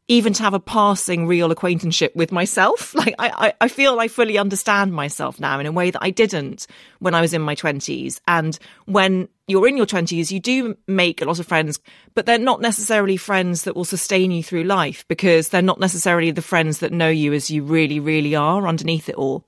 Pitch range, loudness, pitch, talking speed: 165-205 Hz, -19 LUFS, 180 Hz, 220 wpm